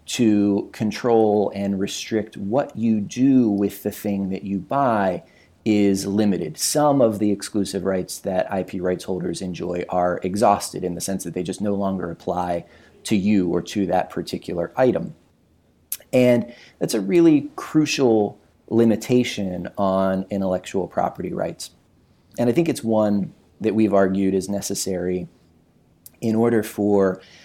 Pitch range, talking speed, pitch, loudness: 95-110 Hz, 145 wpm, 100 Hz, -21 LUFS